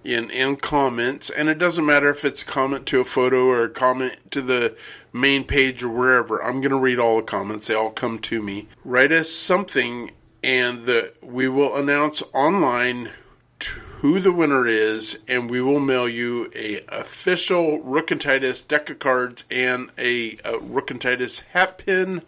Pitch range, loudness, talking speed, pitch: 120-145 Hz, -21 LUFS, 185 wpm, 130 Hz